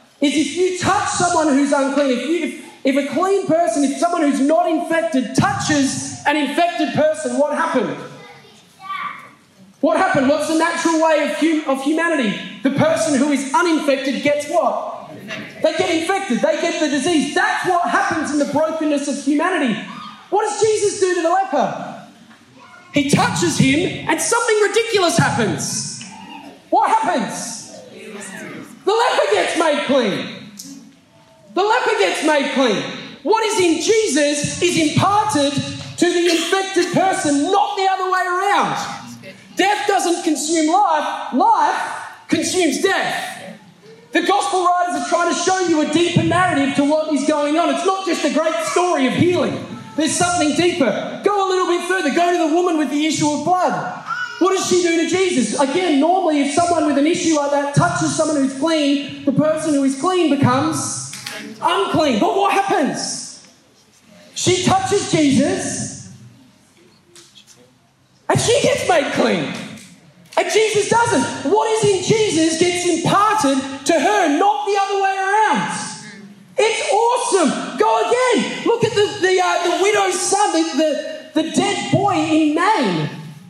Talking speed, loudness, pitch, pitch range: 155 wpm, -17 LUFS, 330 Hz, 290-375 Hz